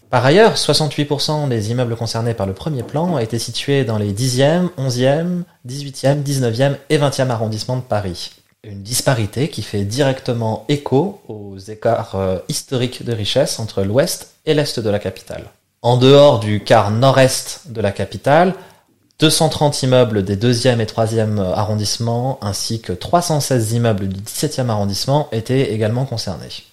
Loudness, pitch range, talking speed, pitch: -17 LUFS, 110-140 Hz, 150 wpm, 125 Hz